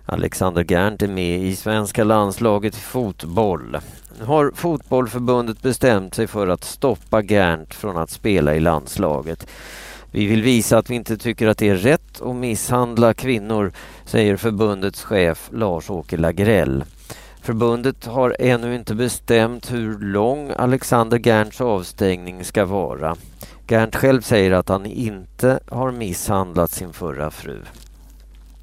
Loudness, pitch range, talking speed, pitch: -19 LUFS, 95-120 Hz, 130 wpm, 110 Hz